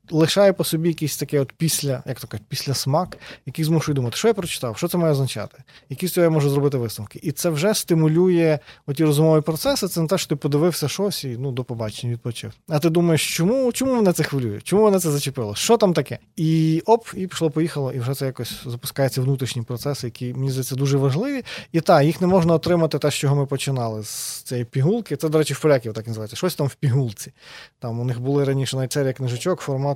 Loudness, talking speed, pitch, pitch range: -21 LUFS, 225 wpm, 145 Hz, 130-165 Hz